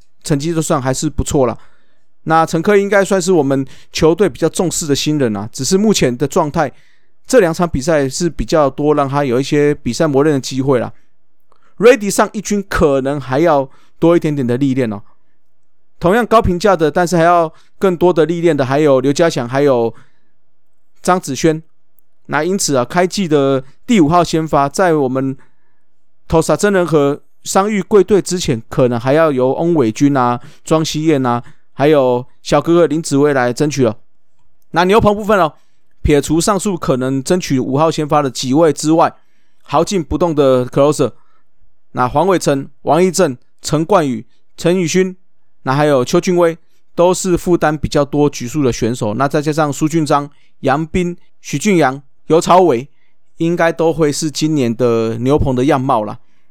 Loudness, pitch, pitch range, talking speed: -14 LUFS, 155 Hz, 135-175 Hz, 270 characters per minute